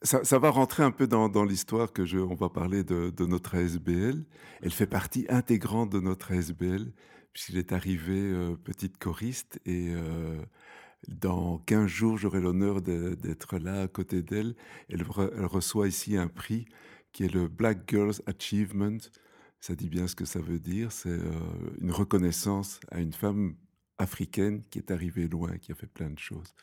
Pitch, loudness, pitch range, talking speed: 95 Hz, -30 LUFS, 90-105 Hz, 185 wpm